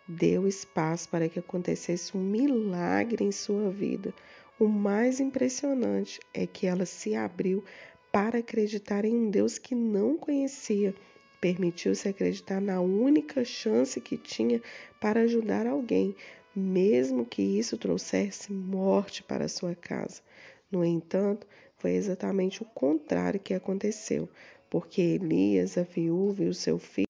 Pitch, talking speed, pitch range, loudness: 195 Hz, 135 wpm, 170-220 Hz, -29 LUFS